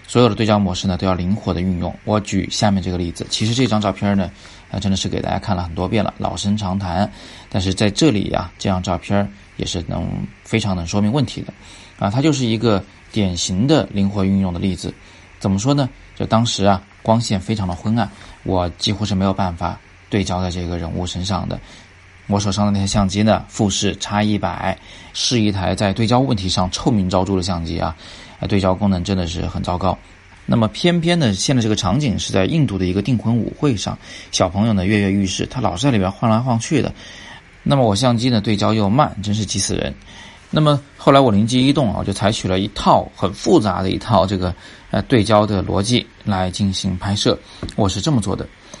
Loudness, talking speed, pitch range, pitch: -18 LUFS, 315 characters per minute, 95-110 Hz, 100 Hz